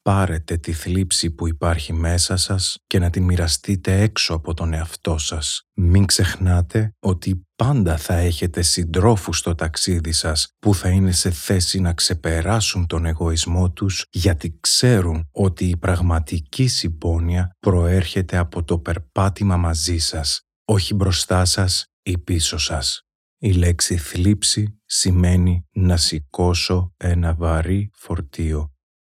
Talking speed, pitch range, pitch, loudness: 130 wpm, 85-95 Hz, 90 Hz, -19 LUFS